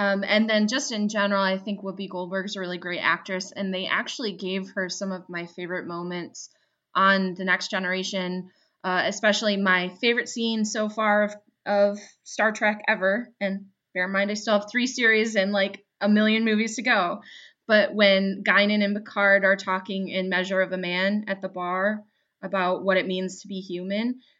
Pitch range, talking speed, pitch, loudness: 185-210 Hz, 195 wpm, 195 Hz, -24 LUFS